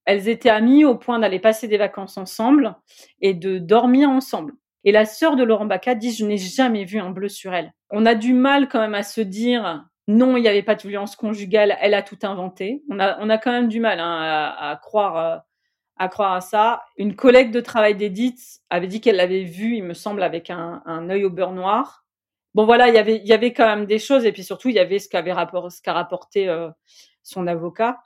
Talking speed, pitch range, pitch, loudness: 240 wpm, 190-235 Hz, 210 Hz, -19 LUFS